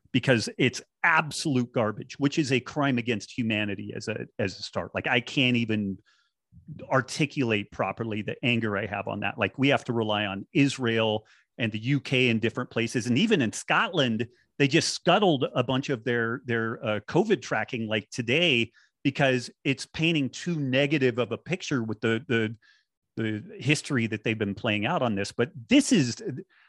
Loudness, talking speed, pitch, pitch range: -26 LUFS, 180 wpm, 120 Hz, 110-140 Hz